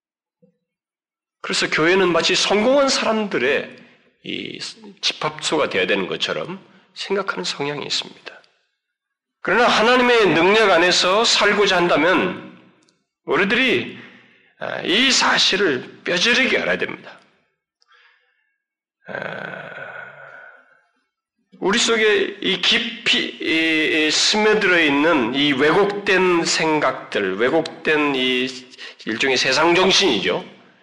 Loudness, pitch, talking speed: -17 LUFS, 195 Hz, 210 characters per minute